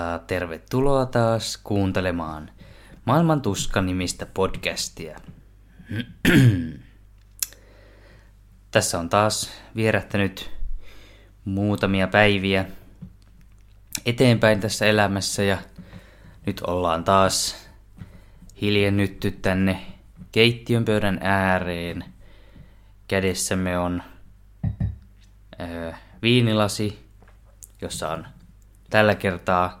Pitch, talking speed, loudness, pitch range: 100 Hz, 60 wpm, -22 LUFS, 95-105 Hz